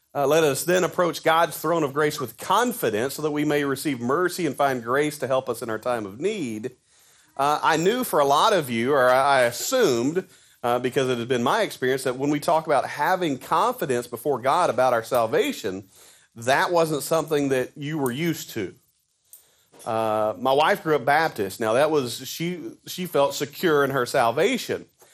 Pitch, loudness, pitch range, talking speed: 145 Hz, -23 LUFS, 125-160 Hz, 195 wpm